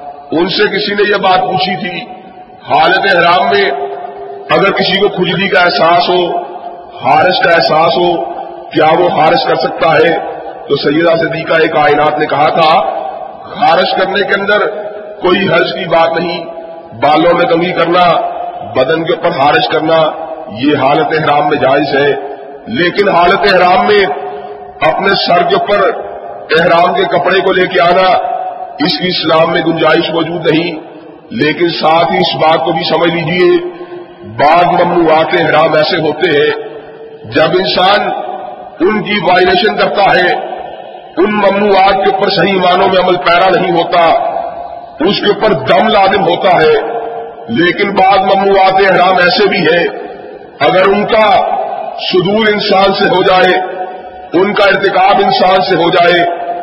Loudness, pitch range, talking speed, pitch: -9 LUFS, 165-205 Hz, 155 wpm, 185 Hz